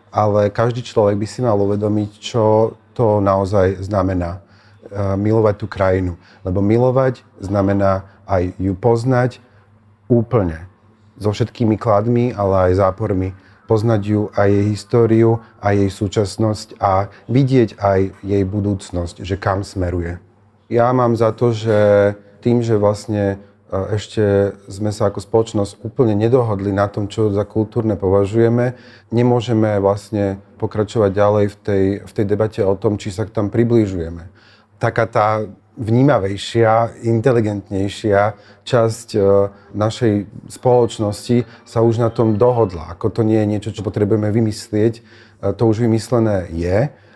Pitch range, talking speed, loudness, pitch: 100-115 Hz, 130 wpm, -17 LUFS, 105 Hz